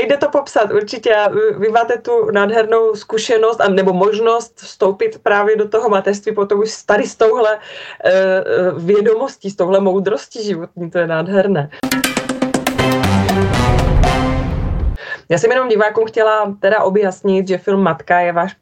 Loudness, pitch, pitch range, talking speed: -15 LUFS, 210 Hz, 190-225 Hz, 140 wpm